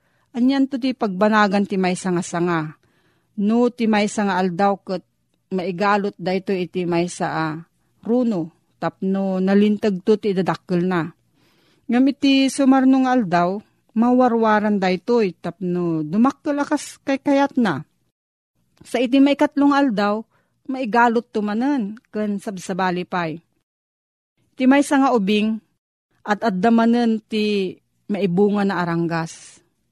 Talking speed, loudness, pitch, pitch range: 125 wpm, -20 LUFS, 210 Hz, 185-245 Hz